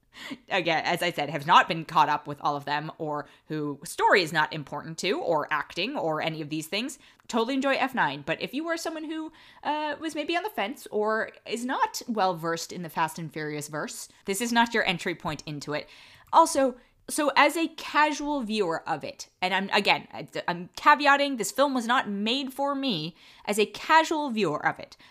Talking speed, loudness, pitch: 210 wpm, -26 LUFS, 210 Hz